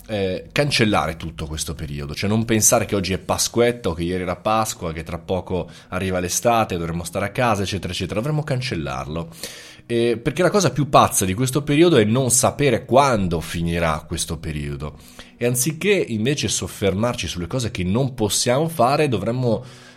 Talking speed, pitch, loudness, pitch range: 170 wpm, 105 Hz, -20 LUFS, 85-120 Hz